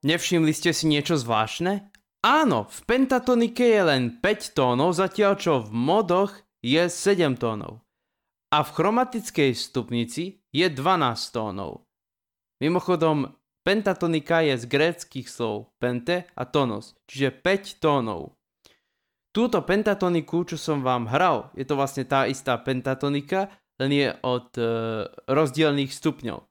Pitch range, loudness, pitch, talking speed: 130-185 Hz, -24 LUFS, 155 Hz, 125 wpm